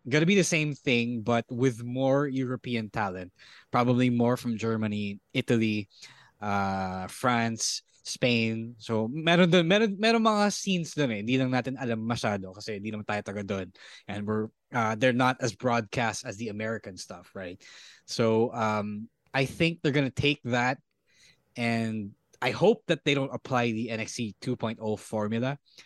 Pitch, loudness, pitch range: 120 Hz, -28 LUFS, 110-135 Hz